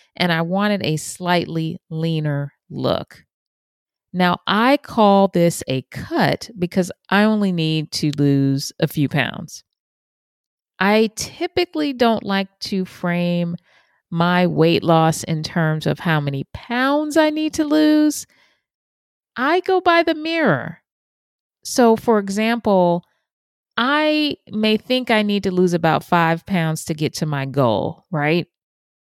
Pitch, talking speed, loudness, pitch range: 180 Hz, 135 wpm, -19 LUFS, 160-225 Hz